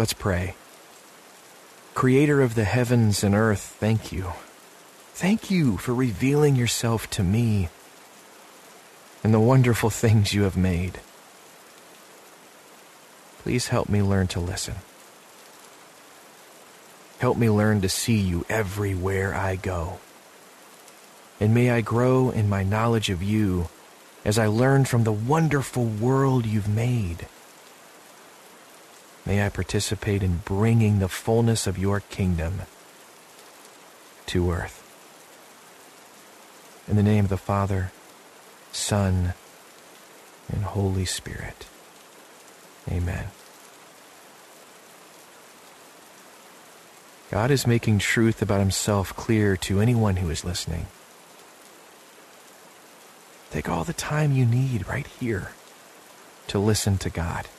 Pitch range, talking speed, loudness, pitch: 95-115 Hz, 110 wpm, -24 LUFS, 105 Hz